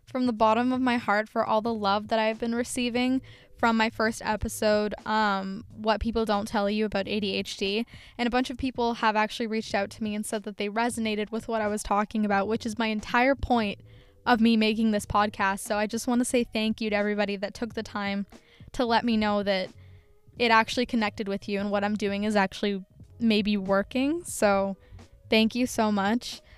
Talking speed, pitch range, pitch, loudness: 215 wpm, 205-230 Hz, 215 Hz, -27 LUFS